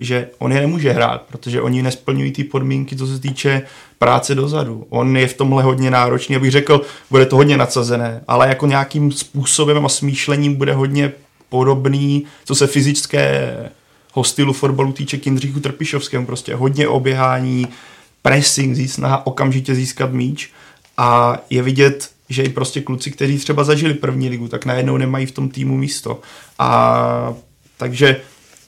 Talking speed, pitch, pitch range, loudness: 155 wpm, 135 Hz, 130-140 Hz, -16 LUFS